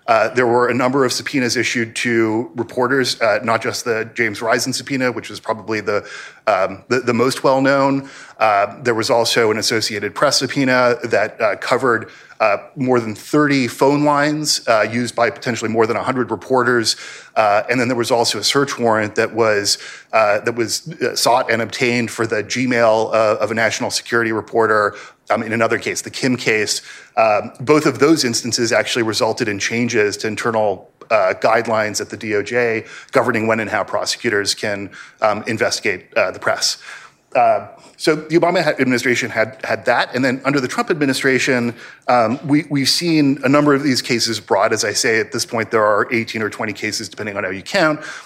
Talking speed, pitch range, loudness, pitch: 190 wpm, 110-135 Hz, -17 LUFS, 120 Hz